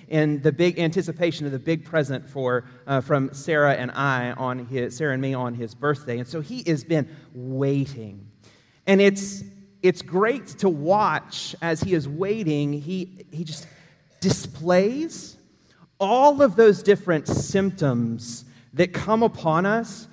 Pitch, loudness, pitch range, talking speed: 155 Hz, -23 LUFS, 135-185 Hz, 150 wpm